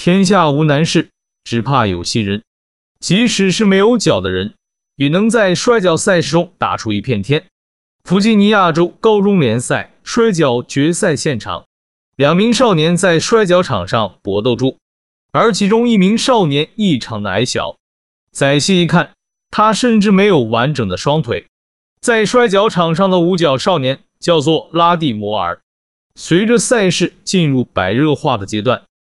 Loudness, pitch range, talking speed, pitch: -13 LUFS, 115-195 Hz, 230 characters per minute, 160 Hz